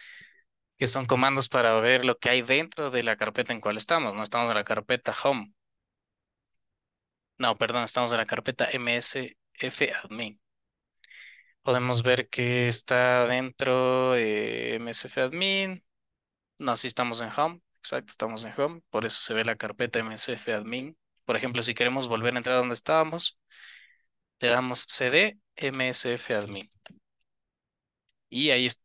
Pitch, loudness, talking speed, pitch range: 125 Hz, -25 LUFS, 150 wpm, 115-130 Hz